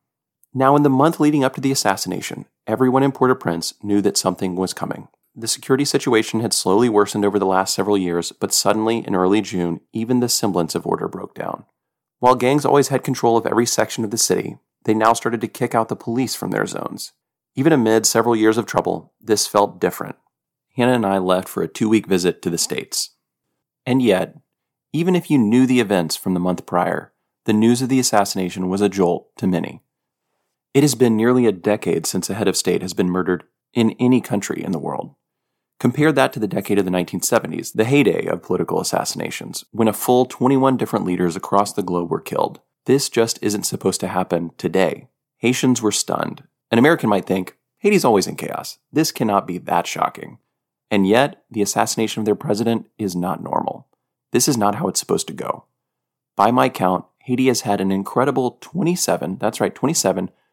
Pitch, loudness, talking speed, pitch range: 110 Hz, -19 LUFS, 200 wpm, 95-130 Hz